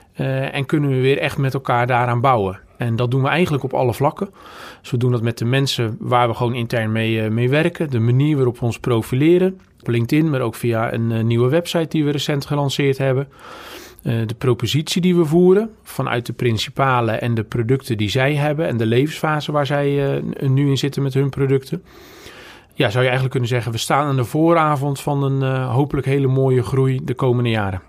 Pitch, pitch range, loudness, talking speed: 135 Hz, 120-145 Hz, -18 LUFS, 215 wpm